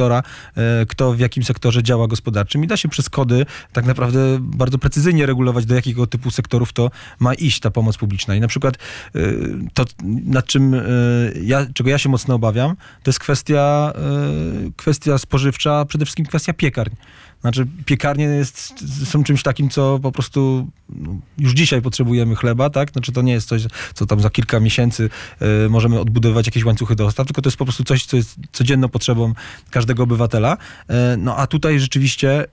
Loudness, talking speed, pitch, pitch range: -17 LUFS, 175 wpm, 125 Hz, 115-140 Hz